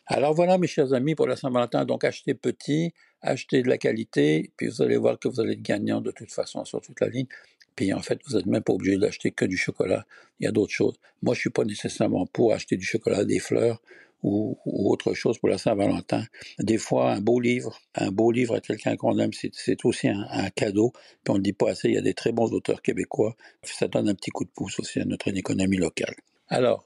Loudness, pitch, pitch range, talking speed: -26 LUFS, 120 Hz, 105-145 Hz, 250 wpm